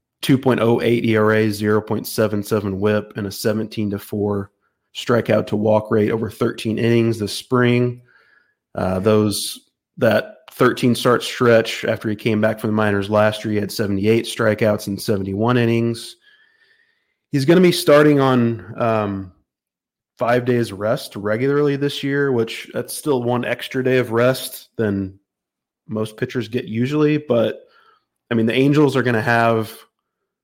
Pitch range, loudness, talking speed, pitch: 105-125 Hz, -19 LUFS, 150 wpm, 115 Hz